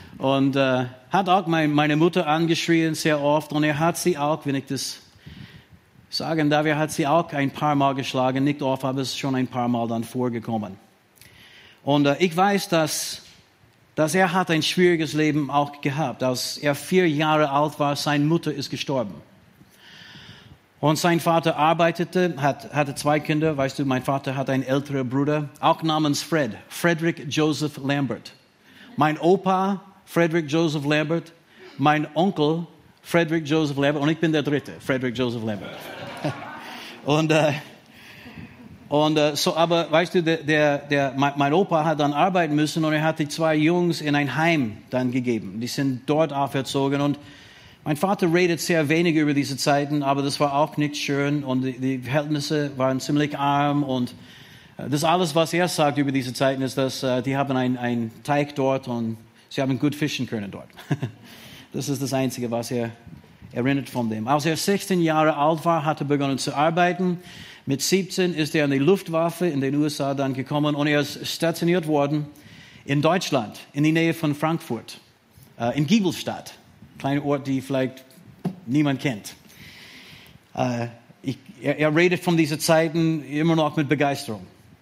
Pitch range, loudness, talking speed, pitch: 135-160 Hz, -23 LUFS, 170 wpm, 145 Hz